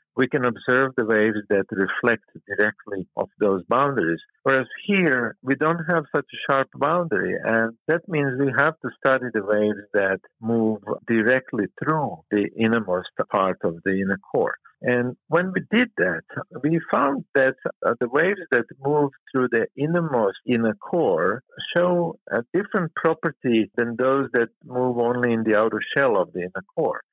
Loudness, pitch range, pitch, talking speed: -23 LUFS, 110-150 Hz, 125 Hz, 165 wpm